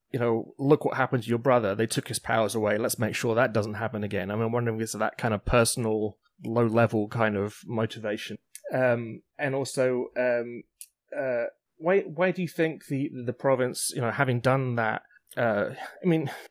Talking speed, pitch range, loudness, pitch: 205 wpm, 110-135 Hz, -27 LUFS, 120 Hz